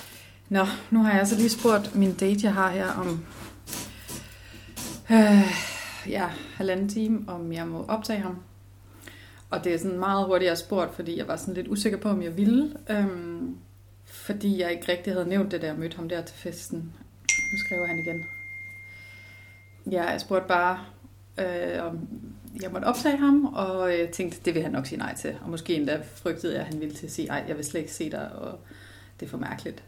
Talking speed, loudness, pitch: 205 wpm, -27 LUFS, 175 Hz